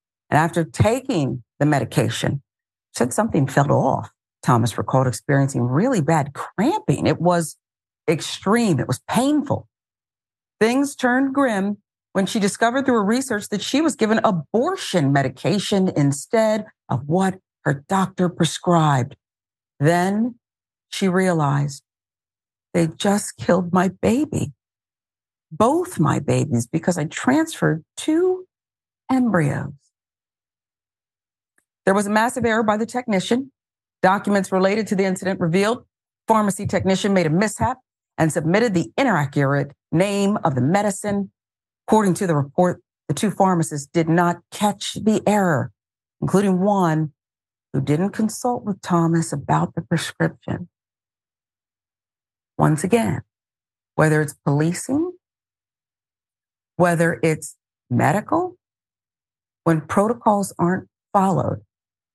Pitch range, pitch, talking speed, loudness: 135-205 Hz, 170 Hz, 115 wpm, -20 LUFS